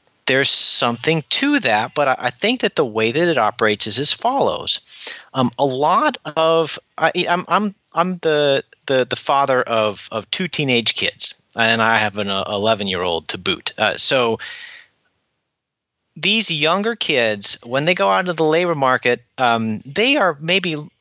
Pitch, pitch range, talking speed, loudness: 140 Hz, 115-175 Hz, 175 wpm, -17 LUFS